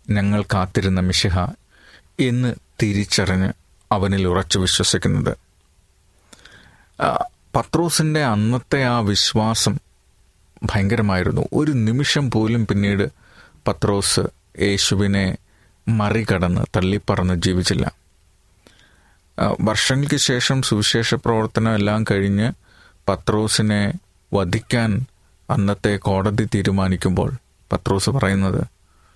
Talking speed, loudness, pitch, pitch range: 70 wpm, -19 LUFS, 100 Hz, 95-115 Hz